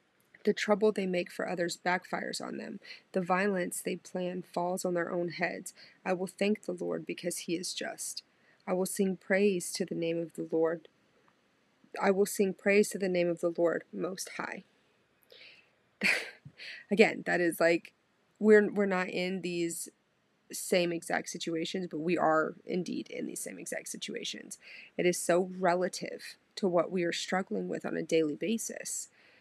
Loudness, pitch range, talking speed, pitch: -32 LUFS, 170-200 Hz, 170 wpm, 180 Hz